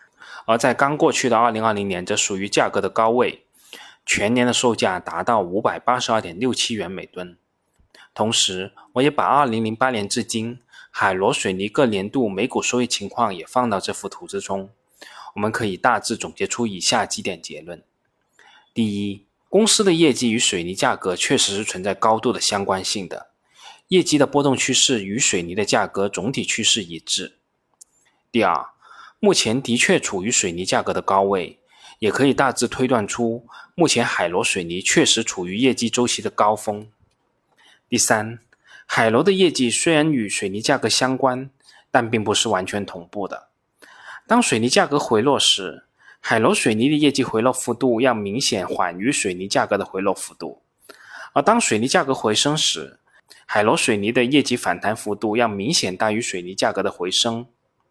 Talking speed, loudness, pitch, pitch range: 250 characters per minute, -20 LUFS, 120 Hz, 105-130 Hz